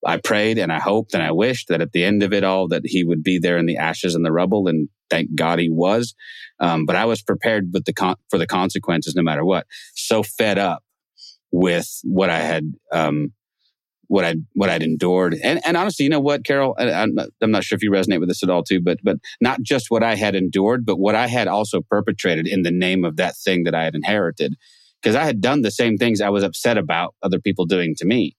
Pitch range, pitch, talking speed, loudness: 85-105 Hz, 95 Hz, 250 wpm, -19 LUFS